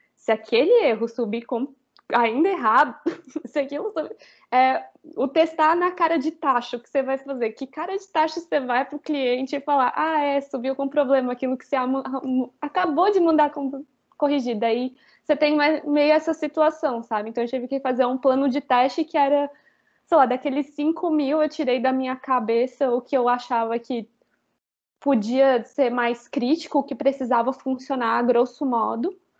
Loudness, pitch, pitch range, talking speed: -22 LUFS, 275 Hz, 250-300 Hz, 175 wpm